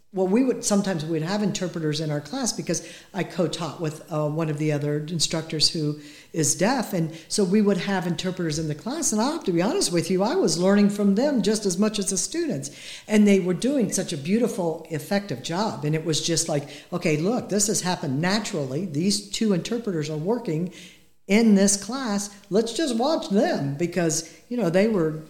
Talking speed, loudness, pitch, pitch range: 210 wpm, -24 LUFS, 180 Hz, 160-205 Hz